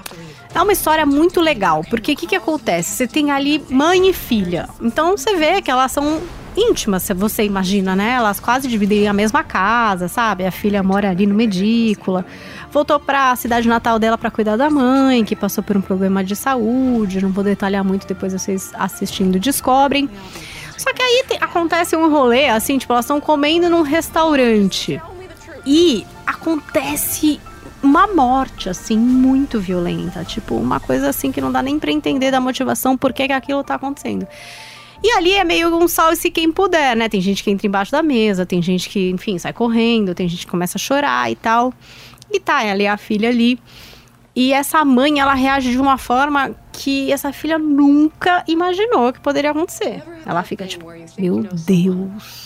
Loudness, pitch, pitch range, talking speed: -16 LUFS, 245 Hz, 200-295 Hz, 185 wpm